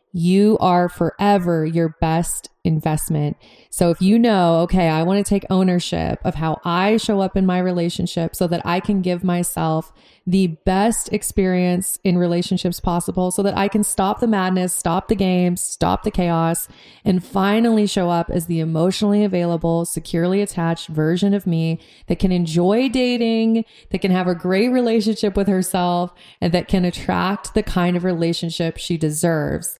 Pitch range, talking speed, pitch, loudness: 170-200 Hz, 170 wpm, 180 Hz, -19 LUFS